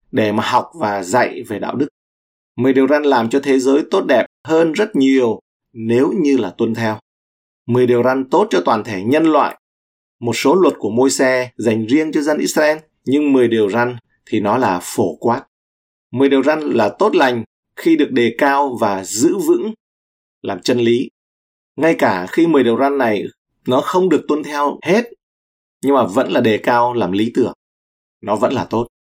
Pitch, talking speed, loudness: 125 Hz, 195 wpm, -16 LUFS